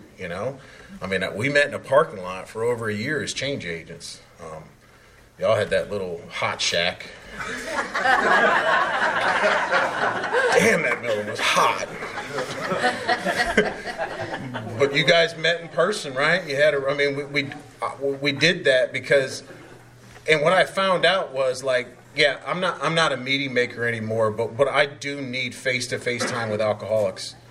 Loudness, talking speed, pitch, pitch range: -22 LUFS, 160 wpm, 135 Hz, 120-145 Hz